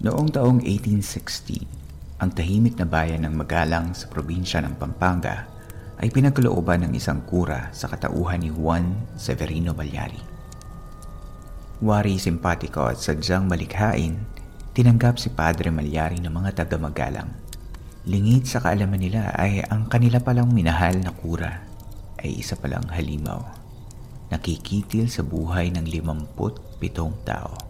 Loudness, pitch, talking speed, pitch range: -23 LUFS, 90 Hz, 130 wpm, 80-110 Hz